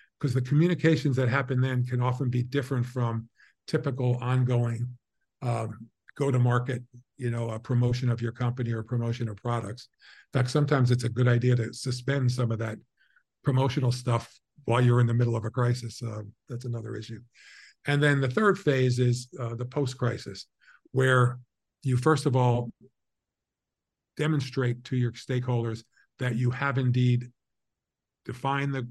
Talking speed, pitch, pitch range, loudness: 160 wpm, 125 Hz, 120-130 Hz, -27 LUFS